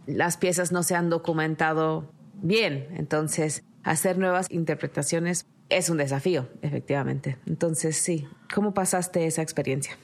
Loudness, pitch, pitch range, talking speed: -26 LUFS, 165 Hz, 155-180 Hz, 125 wpm